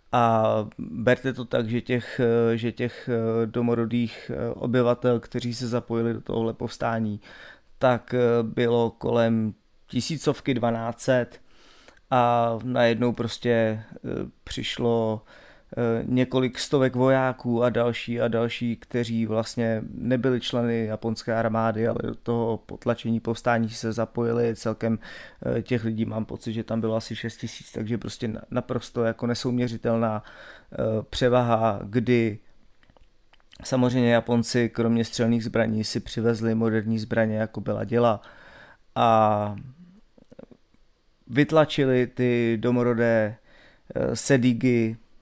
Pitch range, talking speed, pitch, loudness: 115-120 Hz, 105 wpm, 115 Hz, -25 LUFS